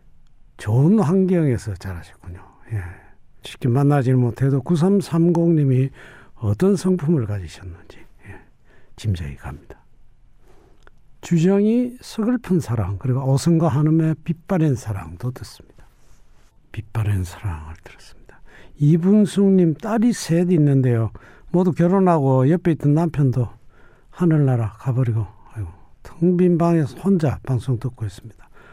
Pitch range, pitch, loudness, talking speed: 105-170 Hz, 135 Hz, -19 LUFS, 260 characters per minute